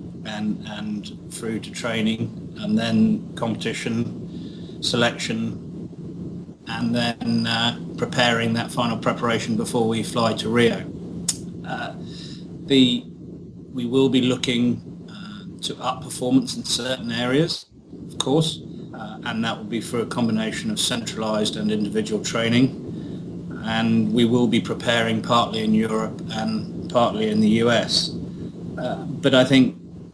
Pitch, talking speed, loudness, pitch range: 125 Hz, 130 wpm, -22 LUFS, 115-175 Hz